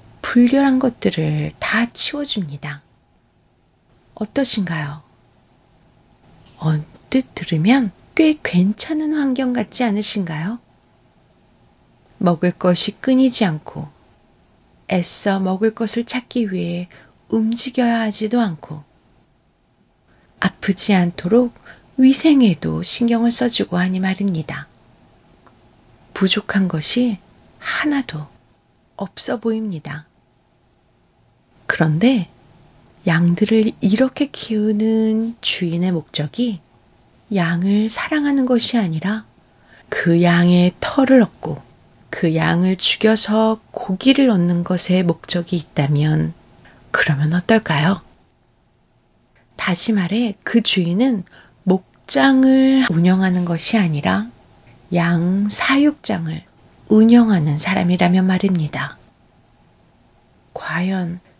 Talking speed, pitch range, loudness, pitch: 195 characters per minute, 170-230 Hz, -17 LUFS, 190 Hz